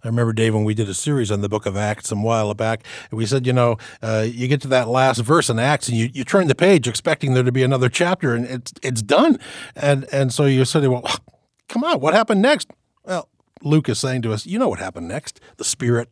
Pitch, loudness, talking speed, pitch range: 125 Hz, -19 LUFS, 255 wpm, 115-140 Hz